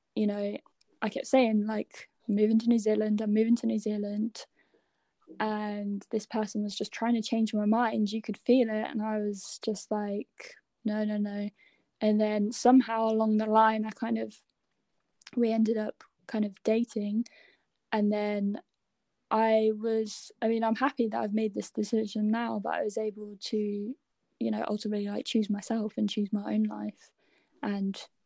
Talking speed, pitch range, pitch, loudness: 180 wpm, 210-225 Hz, 215 Hz, -30 LUFS